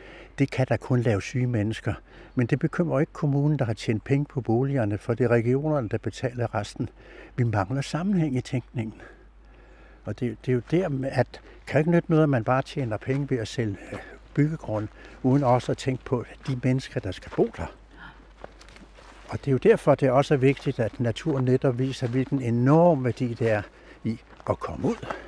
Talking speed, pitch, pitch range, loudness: 200 wpm, 130 Hz, 115-140 Hz, -26 LUFS